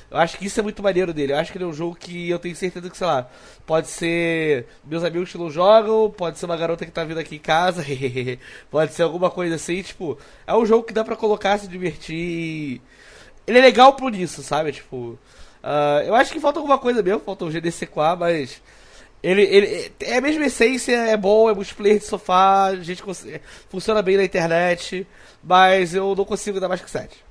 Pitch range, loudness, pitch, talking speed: 165-210 Hz, -20 LUFS, 180 Hz, 220 wpm